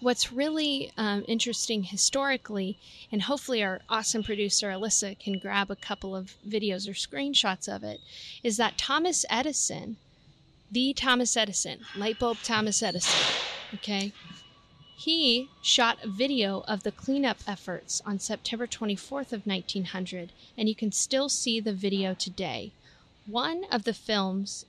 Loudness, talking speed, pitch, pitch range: -28 LUFS, 140 wpm, 210 Hz, 195-240 Hz